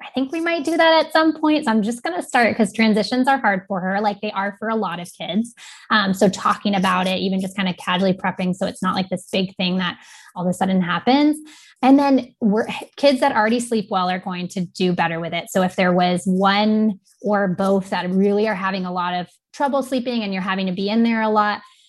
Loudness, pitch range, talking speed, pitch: -20 LUFS, 185-240 Hz, 255 wpm, 205 Hz